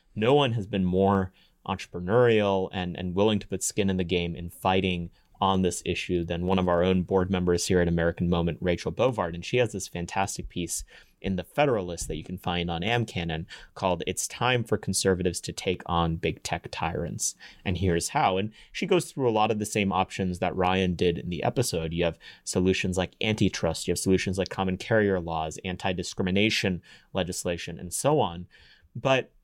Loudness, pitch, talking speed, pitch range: -27 LUFS, 90 Hz, 195 wpm, 85-100 Hz